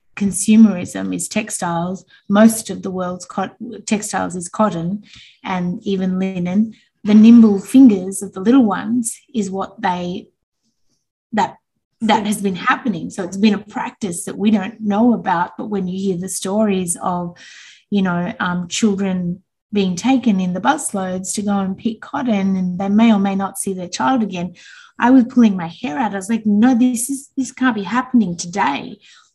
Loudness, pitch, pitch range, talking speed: -17 LUFS, 200 Hz, 185-230 Hz, 180 wpm